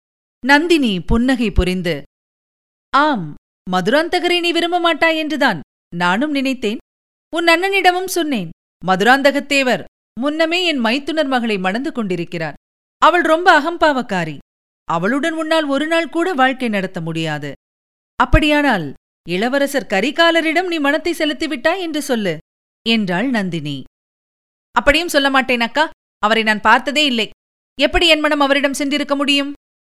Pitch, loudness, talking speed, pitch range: 275 Hz, -16 LUFS, 110 wpm, 195-315 Hz